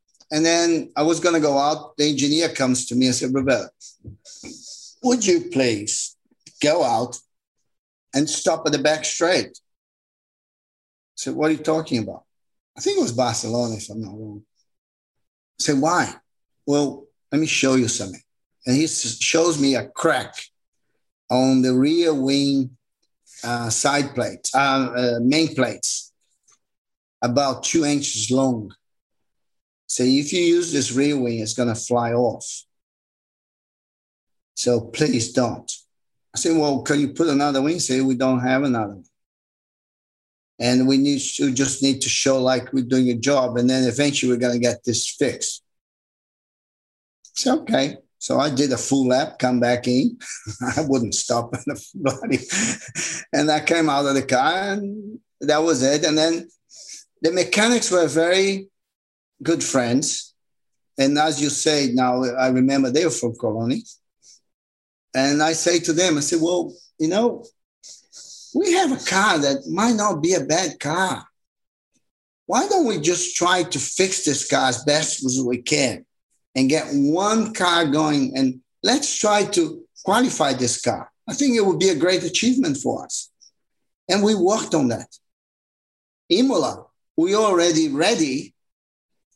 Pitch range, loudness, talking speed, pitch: 125-170 Hz, -20 LUFS, 155 wpm, 140 Hz